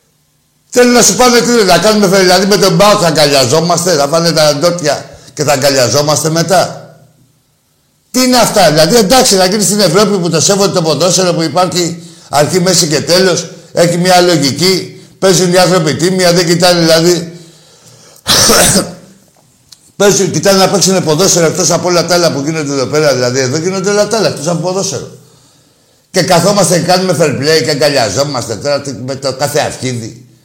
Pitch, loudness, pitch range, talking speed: 175 Hz, -9 LUFS, 150-185 Hz, 170 wpm